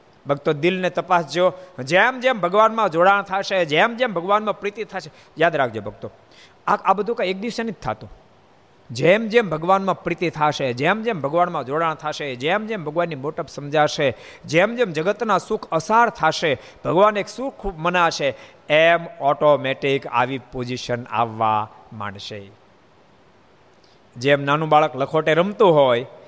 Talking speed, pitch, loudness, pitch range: 140 wpm, 165 Hz, -20 LUFS, 140-195 Hz